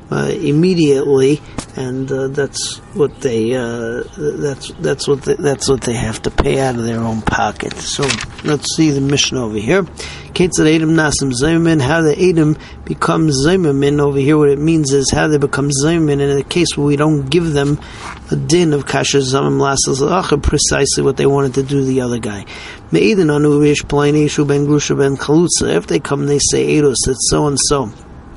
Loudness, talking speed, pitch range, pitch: -14 LUFS, 175 wpm, 130-150 Hz, 140 Hz